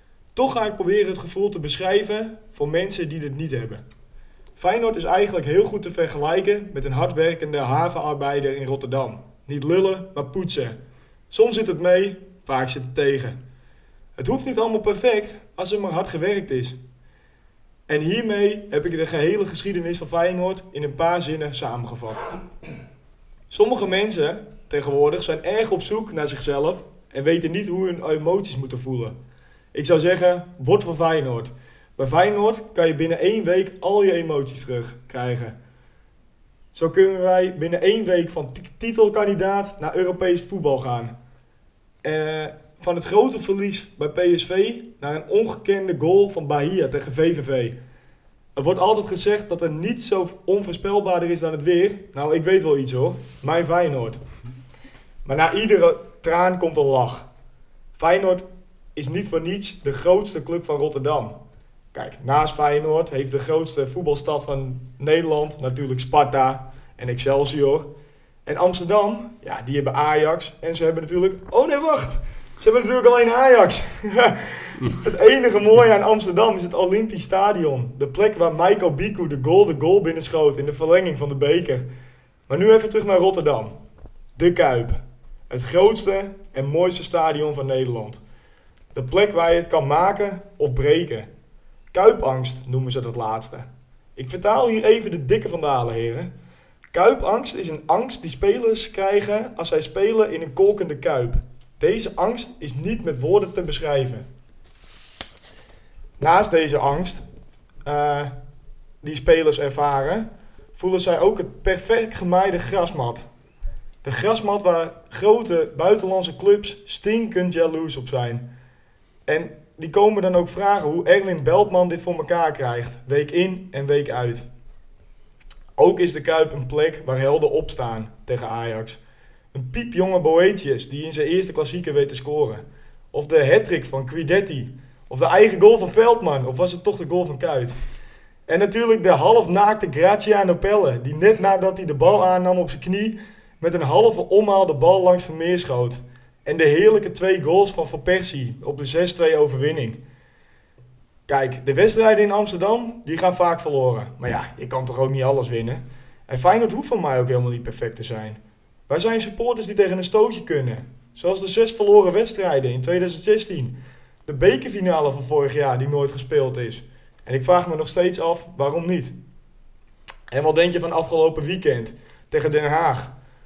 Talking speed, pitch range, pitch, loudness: 165 wpm, 135-195 Hz, 165 Hz, -20 LUFS